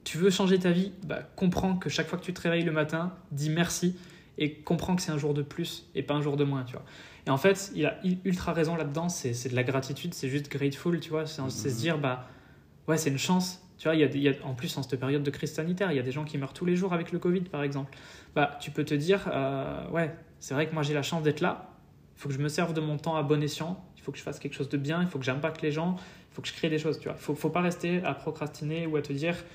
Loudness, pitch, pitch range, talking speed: -30 LUFS, 155 Hz, 145-170 Hz, 310 wpm